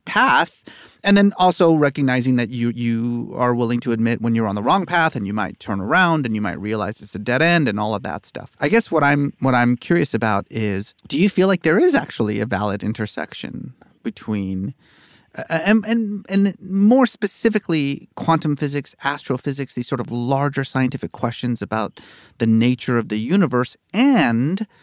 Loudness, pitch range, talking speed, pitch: -19 LUFS, 115-170 Hz, 190 wpm, 130 Hz